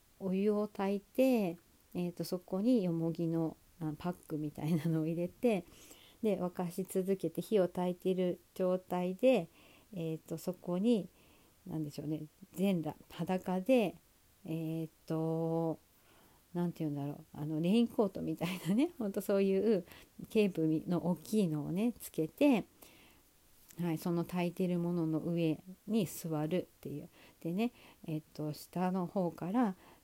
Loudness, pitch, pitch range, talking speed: -35 LUFS, 175 Hz, 160-195 Hz, 275 characters per minute